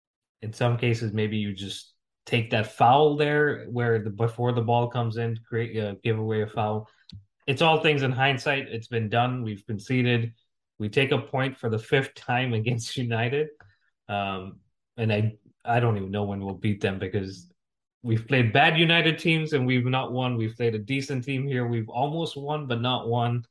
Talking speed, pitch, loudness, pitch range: 190 wpm, 120 Hz, -25 LUFS, 110-130 Hz